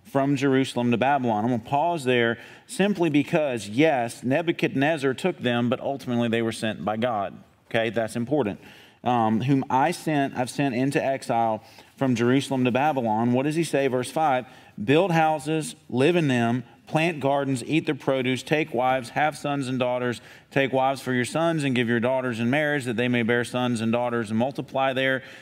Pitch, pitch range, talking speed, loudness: 130 Hz, 120-145 Hz, 190 wpm, -24 LUFS